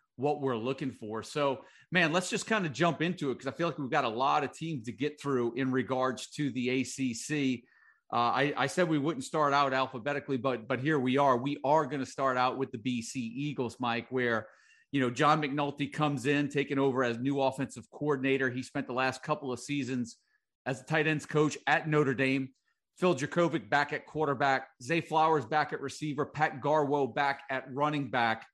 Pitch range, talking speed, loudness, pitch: 130-150 Hz, 210 wpm, -31 LUFS, 140 Hz